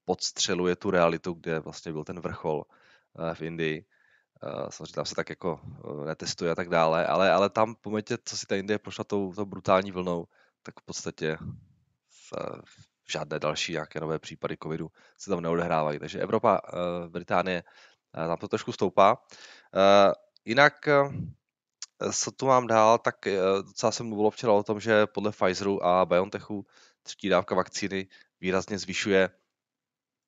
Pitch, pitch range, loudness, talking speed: 95 Hz, 85-105 Hz, -27 LUFS, 150 wpm